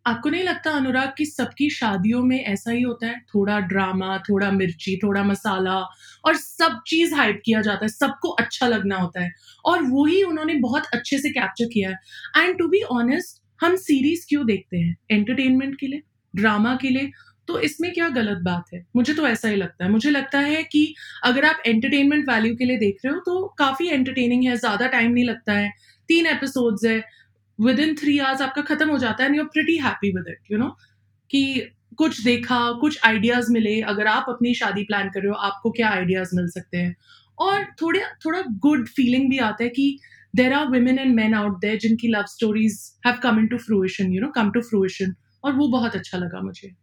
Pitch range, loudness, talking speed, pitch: 205-285 Hz, -21 LUFS, 190 wpm, 240 Hz